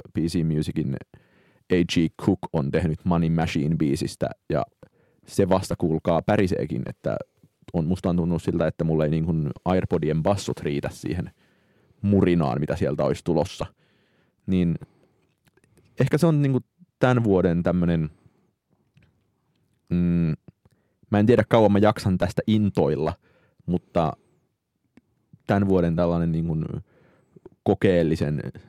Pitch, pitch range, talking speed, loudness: 90 Hz, 85-105 Hz, 125 wpm, -24 LUFS